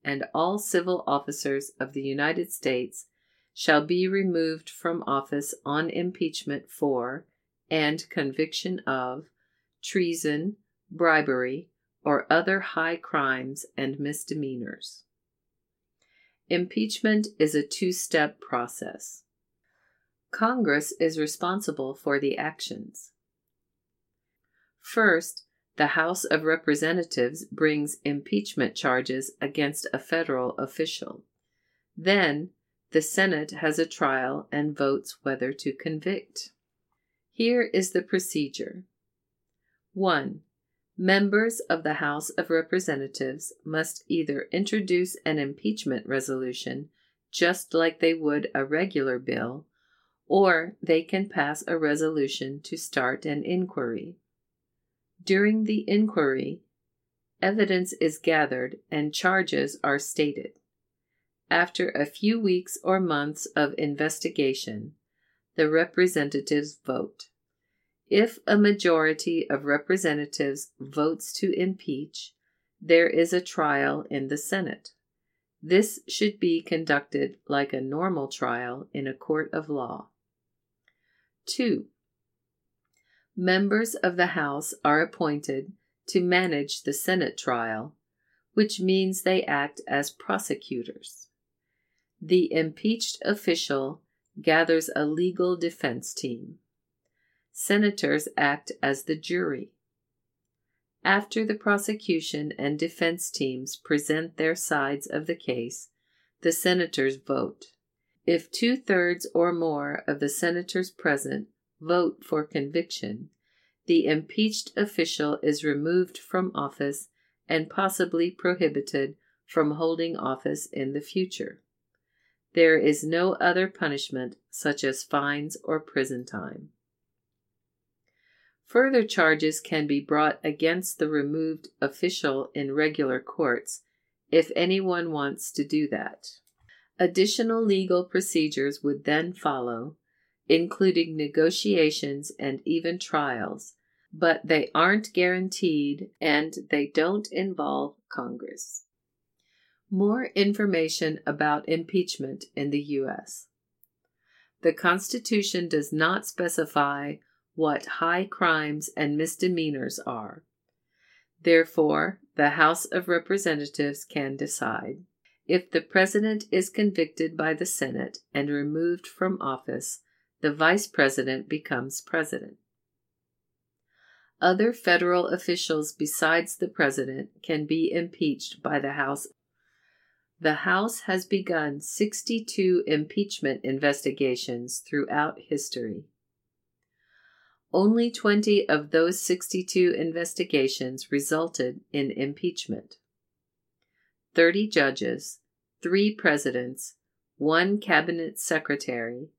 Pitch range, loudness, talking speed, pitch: 145-180 Hz, -26 LUFS, 105 wpm, 160 Hz